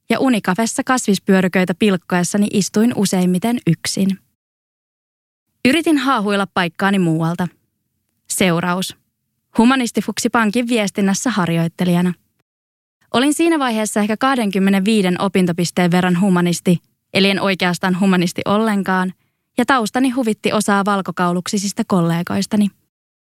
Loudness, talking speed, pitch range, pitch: -17 LUFS, 90 wpm, 180-220 Hz, 195 Hz